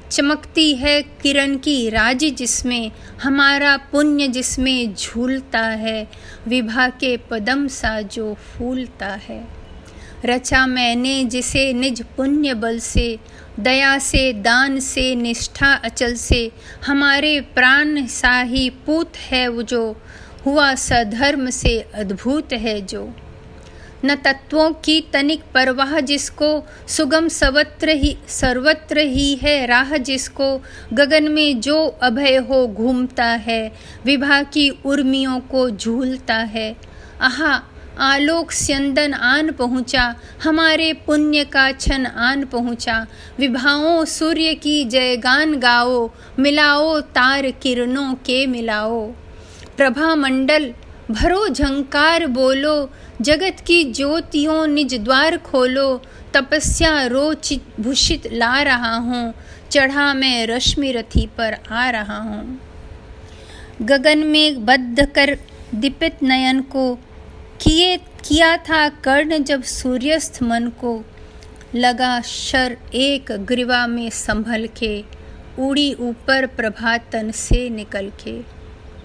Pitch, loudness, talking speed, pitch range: 265 Hz, -17 LUFS, 110 wpm, 240-290 Hz